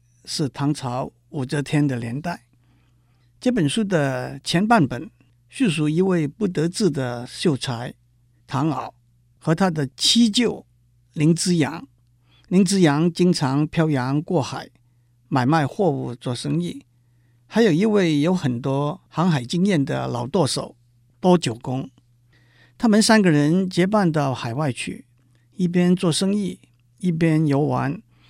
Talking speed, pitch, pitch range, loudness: 190 characters per minute, 145 Hz, 120-175 Hz, -21 LUFS